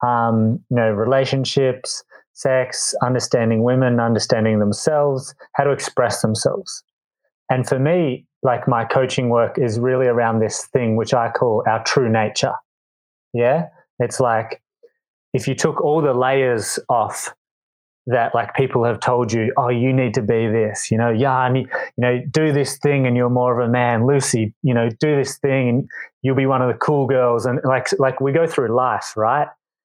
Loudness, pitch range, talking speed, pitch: -19 LUFS, 115-135 Hz, 185 wpm, 125 Hz